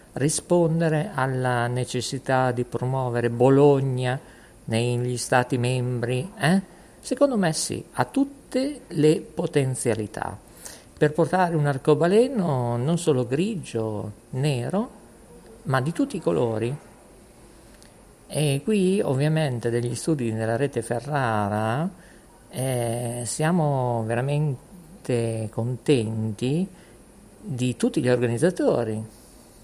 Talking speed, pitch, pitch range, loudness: 95 wpm, 130 Hz, 120-165 Hz, -24 LUFS